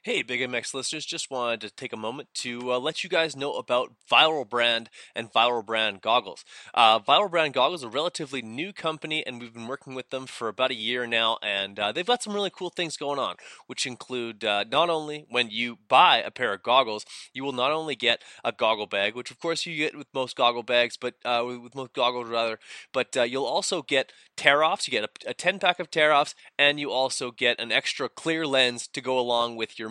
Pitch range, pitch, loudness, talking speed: 120-150 Hz, 125 Hz, -25 LUFS, 230 wpm